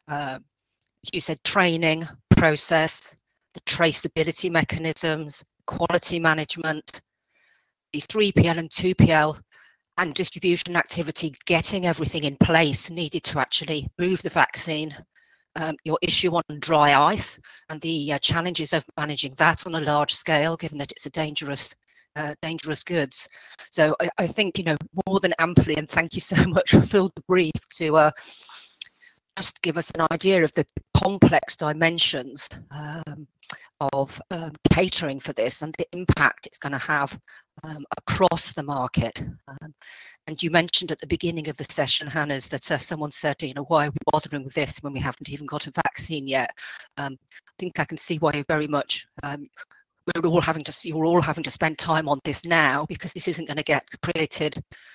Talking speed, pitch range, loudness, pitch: 175 wpm, 150-170 Hz, -23 LUFS, 160 Hz